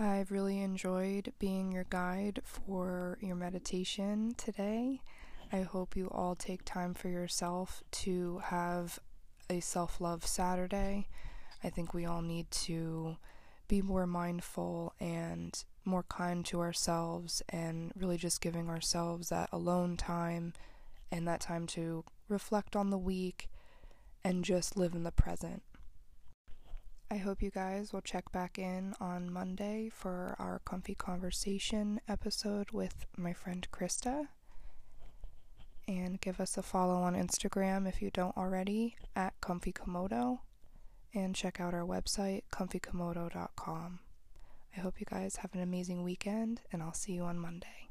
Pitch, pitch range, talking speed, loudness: 185 Hz, 175-195 Hz, 140 wpm, -38 LUFS